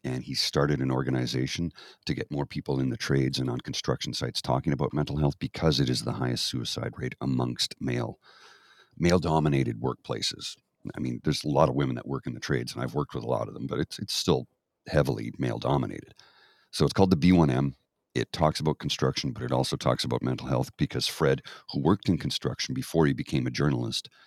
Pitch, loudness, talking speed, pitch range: 65 Hz, -28 LUFS, 215 wpm, 65-75 Hz